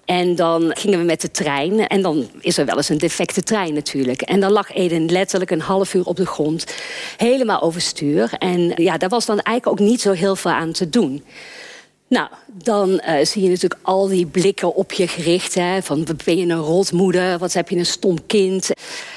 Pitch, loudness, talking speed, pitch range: 185 Hz, -18 LUFS, 215 wpm, 170-200 Hz